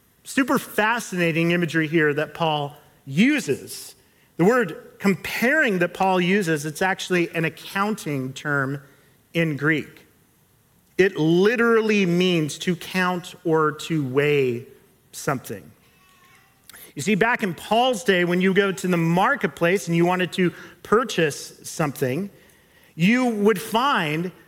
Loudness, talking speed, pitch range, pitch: -22 LUFS, 125 wpm, 155-200 Hz, 175 Hz